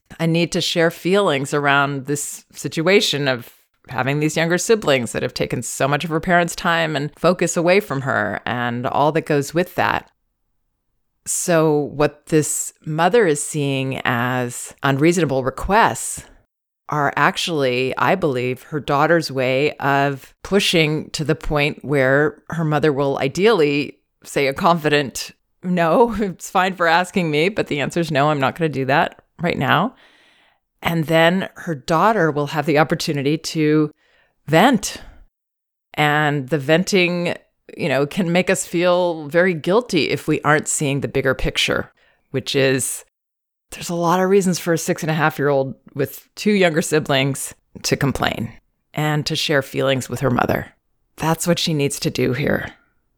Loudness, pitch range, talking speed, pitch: -19 LUFS, 140-170 Hz, 160 wpm, 155 Hz